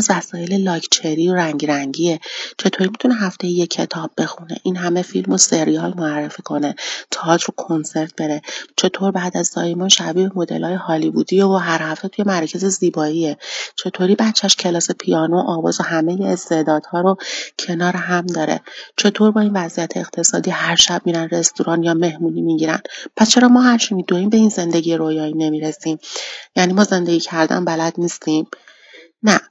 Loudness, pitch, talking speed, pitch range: -17 LUFS, 175 Hz, 155 wpm, 160-190 Hz